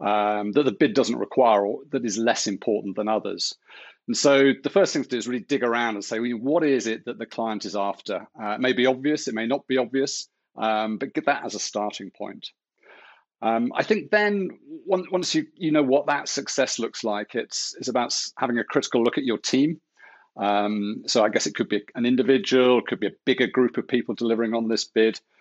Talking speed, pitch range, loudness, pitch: 230 wpm, 110-140 Hz, -24 LUFS, 125 Hz